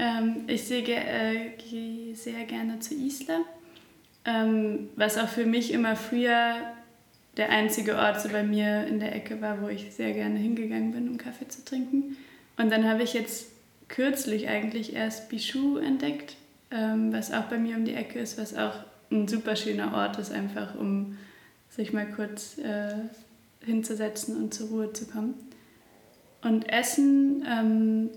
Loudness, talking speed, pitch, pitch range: -29 LUFS, 160 wpm, 225 Hz, 215-240 Hz